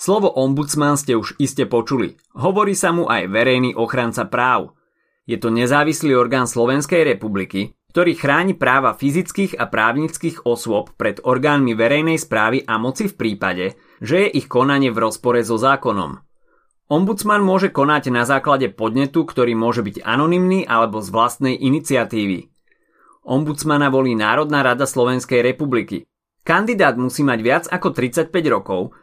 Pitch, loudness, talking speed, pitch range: 135 Hz, -18 LUFS, 145 wpm, 120-155 Hz